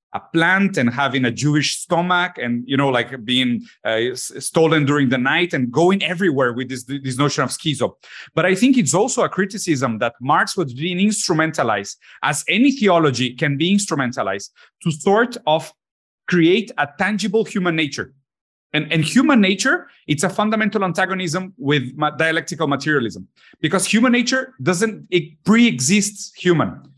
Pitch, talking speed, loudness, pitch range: 170 Hz, 160 wpm, -18 LUFS, 145-200 Hz